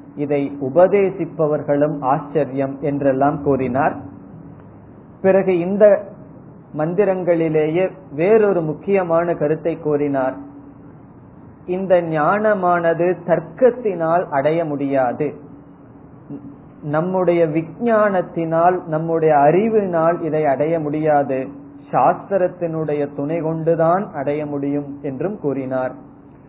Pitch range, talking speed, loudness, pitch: 145-180 Hz, 70 wpm, -18 LUFS, 160 Hz